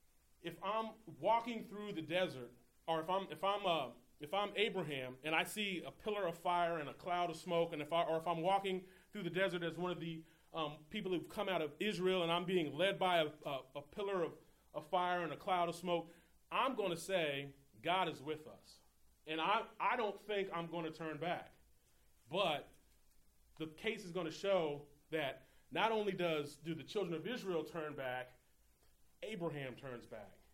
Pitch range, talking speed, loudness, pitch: 150-190 Hz, 205 wpm, -40 LUFS, 170 Hz